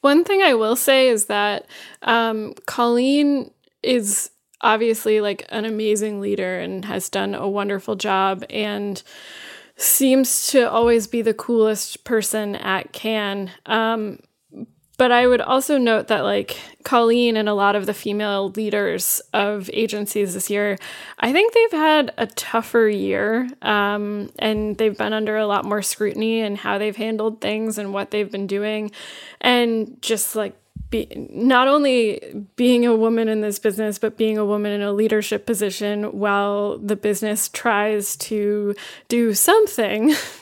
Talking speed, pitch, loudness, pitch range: 155 wpm, 215 Hz, -20 LUFS, 205-235 Hz